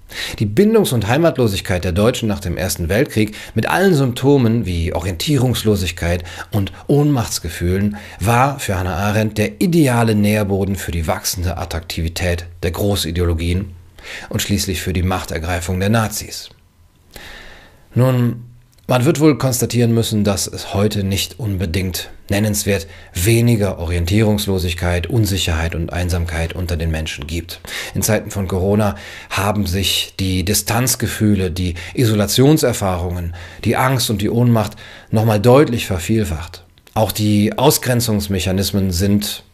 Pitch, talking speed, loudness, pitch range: 100 Hz, 120 wpm, -17 LUFS, 90-110 Hz